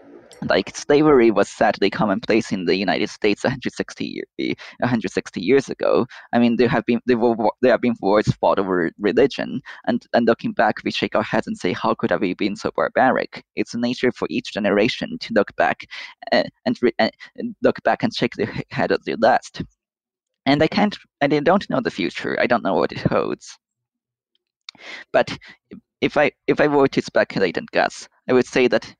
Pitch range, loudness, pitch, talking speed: 120-155 Hz, -20 LUFS, 125 Hz, 190 wpm